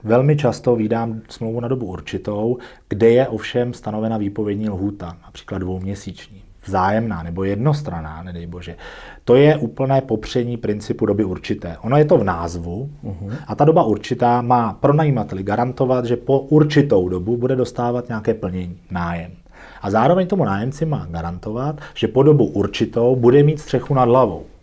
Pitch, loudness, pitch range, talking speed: 115 Hz, -19 LUFS, 95-125 Hz, 155 wpm